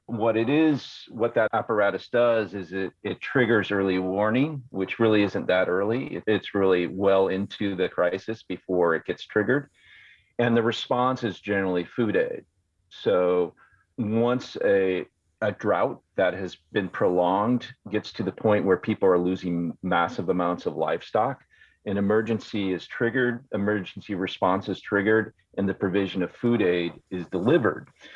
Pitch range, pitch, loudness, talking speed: 95-115 Hz, 100 Hz, -25 LUFS, 155 wpm